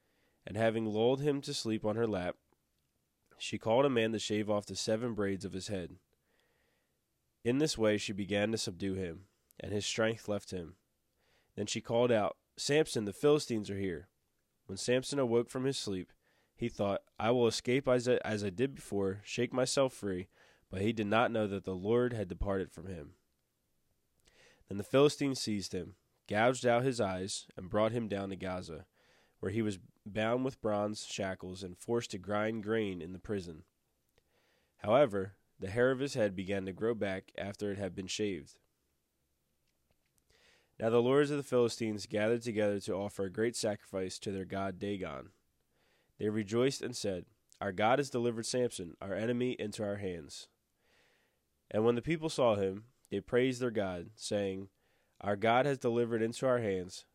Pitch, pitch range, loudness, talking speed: 105 Hz, 95-120 Hz, -34 LUFS, 180 wpm